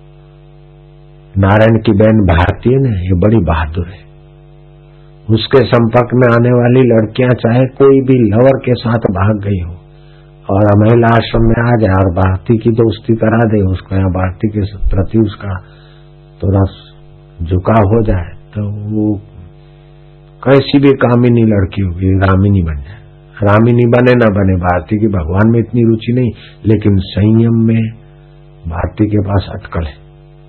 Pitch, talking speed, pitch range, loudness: 115 Hz, 150 wpm, 100-135 Hz, -11 LUFS